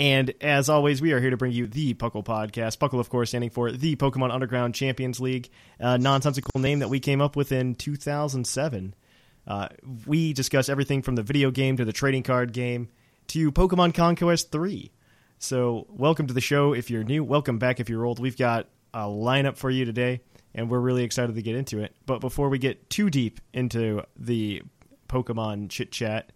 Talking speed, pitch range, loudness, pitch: 200 wpm, 120-140 Hz, -26 LUFS, 130 Hz